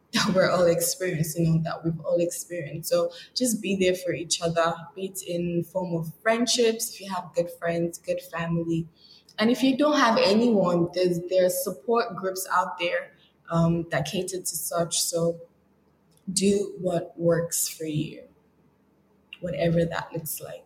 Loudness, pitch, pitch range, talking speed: -25 LUFS, 175 Hz, 170-190 Hz, 165 wpm